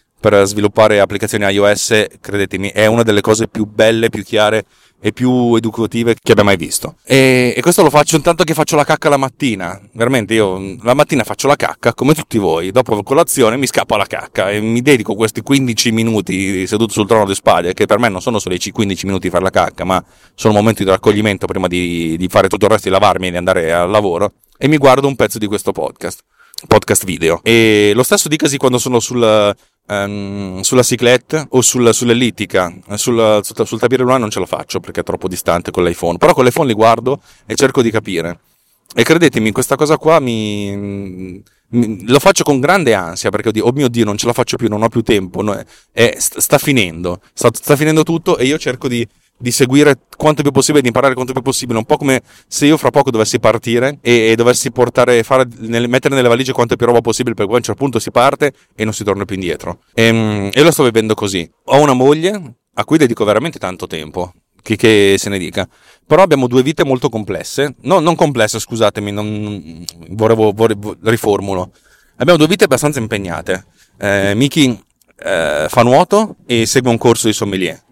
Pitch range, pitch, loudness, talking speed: 100-130 Hz, 115 Hz, -13 LUFS, 210 wpm